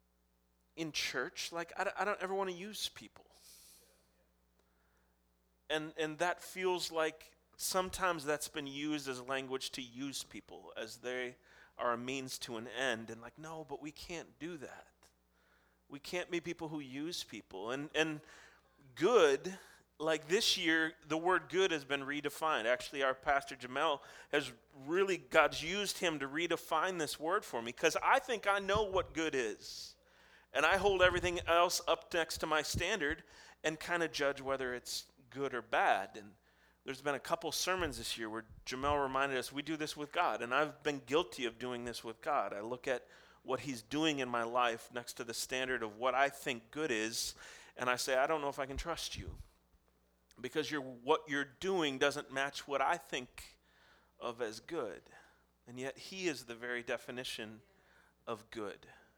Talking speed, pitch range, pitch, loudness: 185 wpm, 120-160 Hz, 140 Hz, -36 LUFS